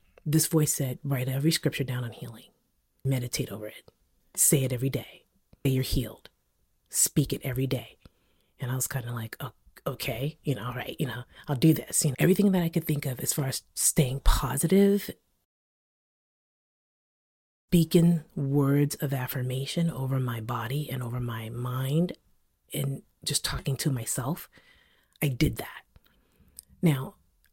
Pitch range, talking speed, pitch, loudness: 125-155 Hz, 155 wpm, 135 Hz, -28 LUFS